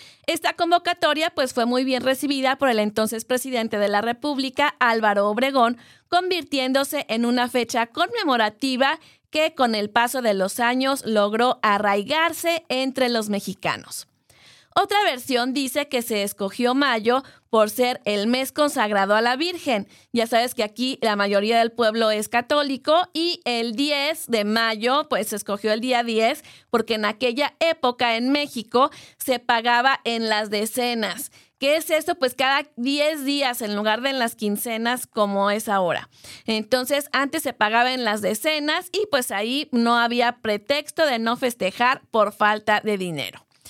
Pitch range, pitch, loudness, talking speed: 220-280 Hz, 245 Hz, -22 LUFS, 160 wpm